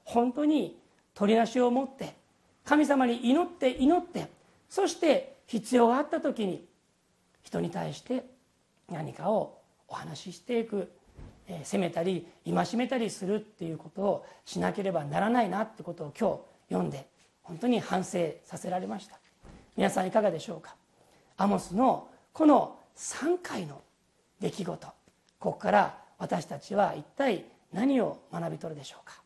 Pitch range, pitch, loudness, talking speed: 185-270 Hz, 235 Hz, -30 LUFS, 280 characters per minute